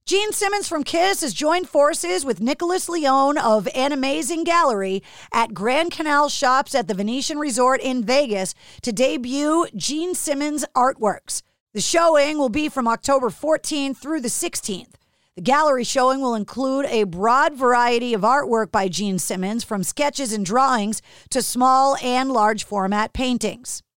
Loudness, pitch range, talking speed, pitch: -20 LUFS, 230-300 Hz, 155 wpm, 265 Hz